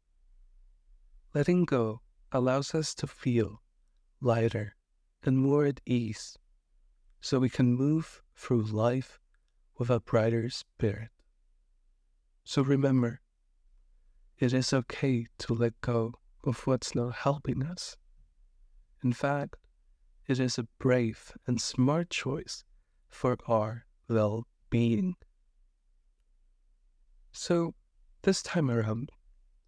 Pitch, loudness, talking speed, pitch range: 115 Hz, -30 LUFS, 105 wpm, 85-130 Hz